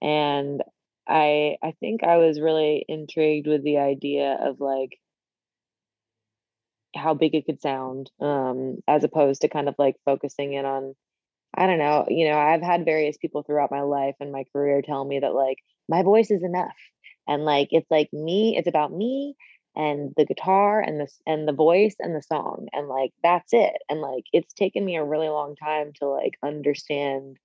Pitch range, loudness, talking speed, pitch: 140-160 Hz, -23 LUFS, 190 wpm, 150 Hz